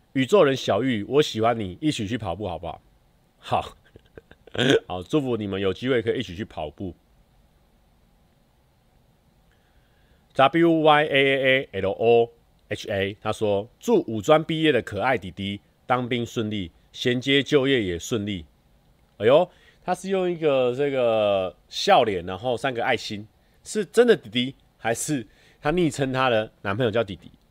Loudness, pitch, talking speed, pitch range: -23 LUFS, 120 Hz, 215 characters per minute, 100-140 Hz